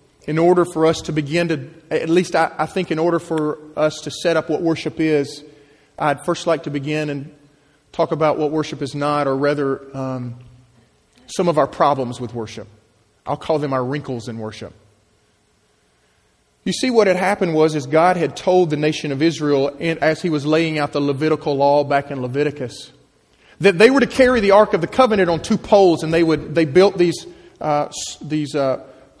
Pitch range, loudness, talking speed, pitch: 140-165 Hz, -18 LUFS, 200 wpm, 150 Hz